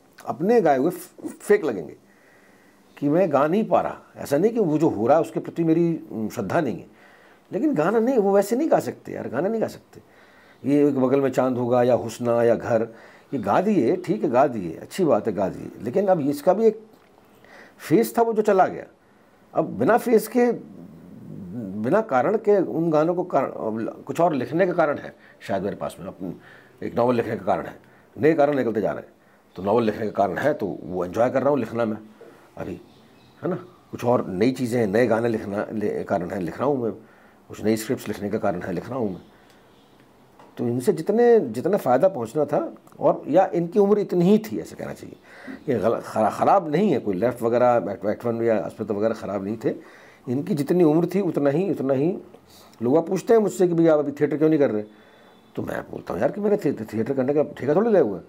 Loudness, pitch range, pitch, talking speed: -22 LUFS, 110-180 Hz, 140 Hz, 220 wpm